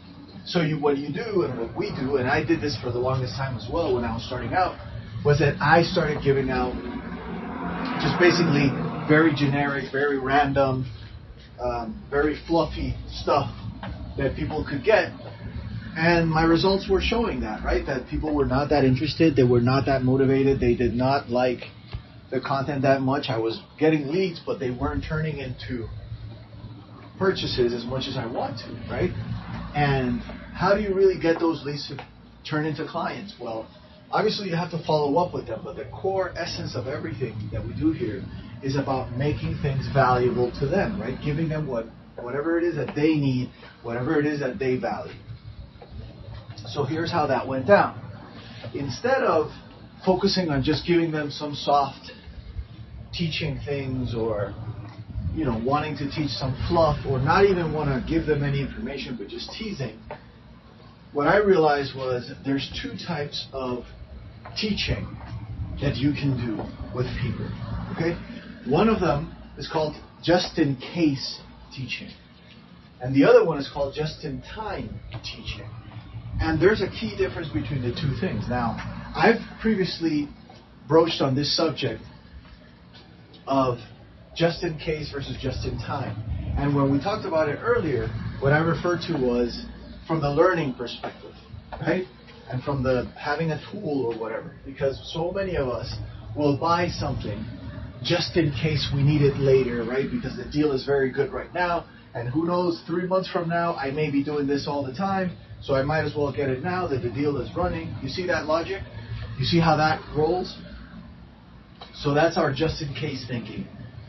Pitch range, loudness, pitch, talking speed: 125-160 Hz, -25 LUFS, 140 Hz, 175 wpm